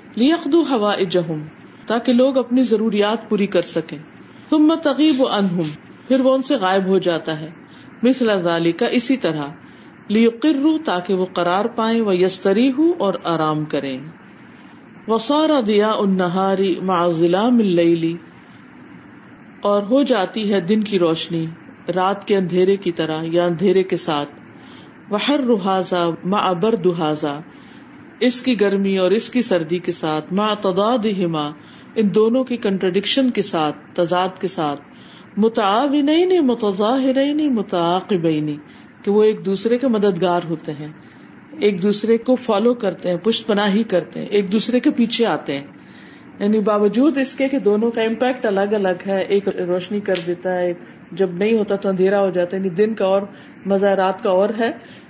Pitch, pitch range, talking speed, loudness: 200 Hz, 180-240 Hz, 150 wpm, -18 LUFS